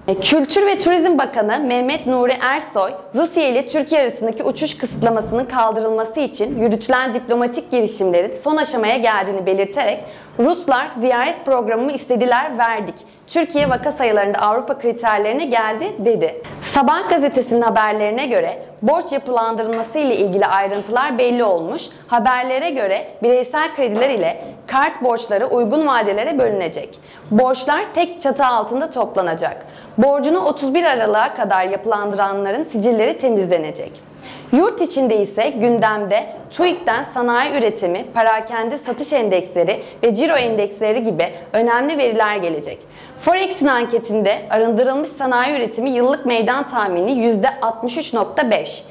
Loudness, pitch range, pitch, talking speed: -17 LUFS, 220-280 Hz, 245 Hz, 115 wpm